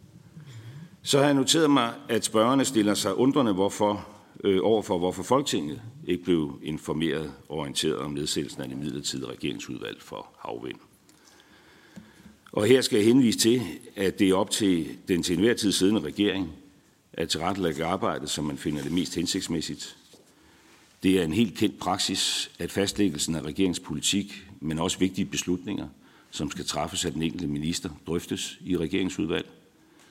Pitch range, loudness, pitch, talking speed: 85-110 Hz, -26 LUFS, 95 Hz, 155 wpm